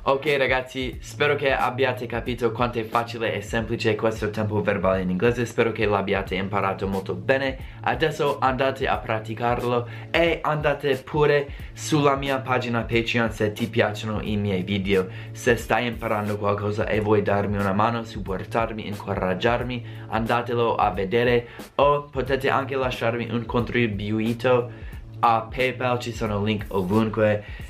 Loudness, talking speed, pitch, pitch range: -24 LUFS, 140 wpm, 115 Hz, 105-125 Hz